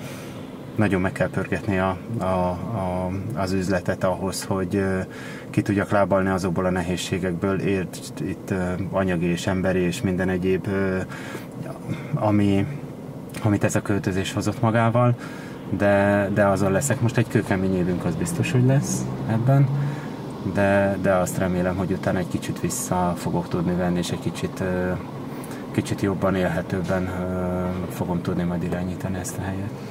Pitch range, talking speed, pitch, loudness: 90-100 Hz, 150 wpm, 95 Hz, -24 LUFS